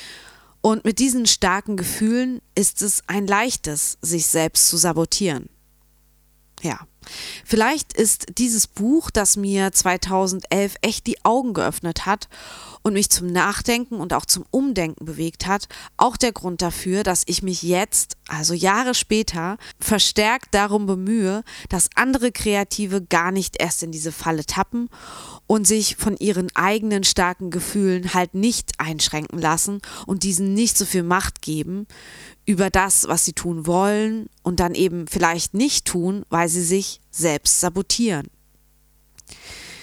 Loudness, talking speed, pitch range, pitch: -20 LUFS, 145 wpm, 170-215 Hz, 190 Hz